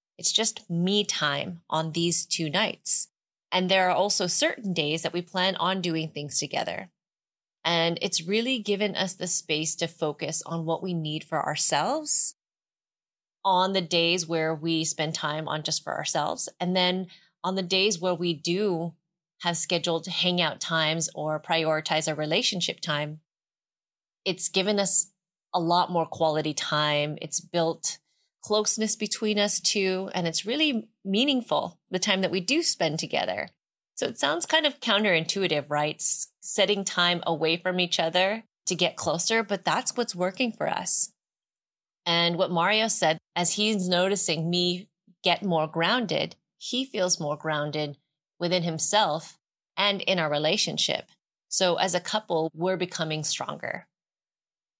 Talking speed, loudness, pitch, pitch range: 150 wpm, -25 LUFS, 175 Hz, 160-195 Hz